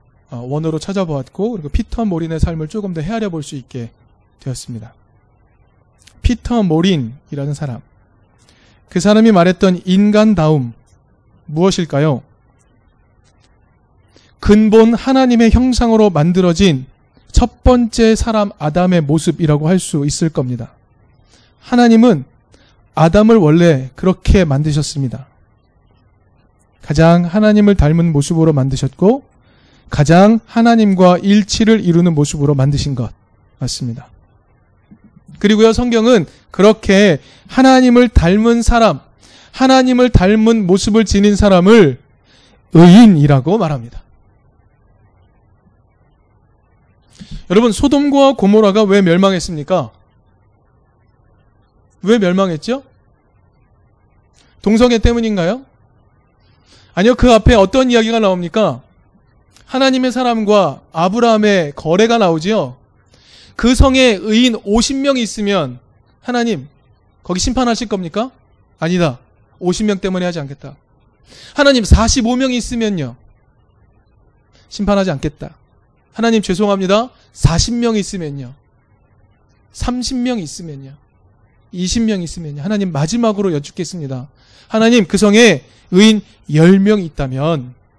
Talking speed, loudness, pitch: 245 characters per minute, -13 LUFS, 165 Hz